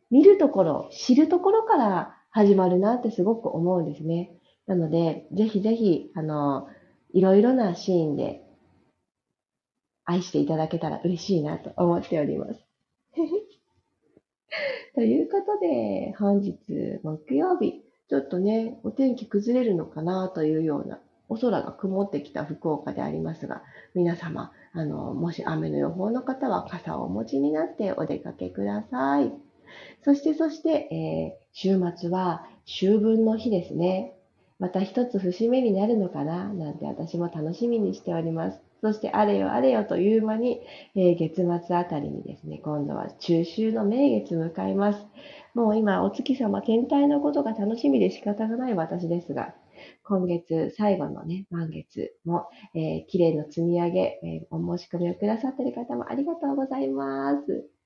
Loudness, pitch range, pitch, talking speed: -26 LUFS, 165-235 Hz, 190 Hz, 305 characters per minute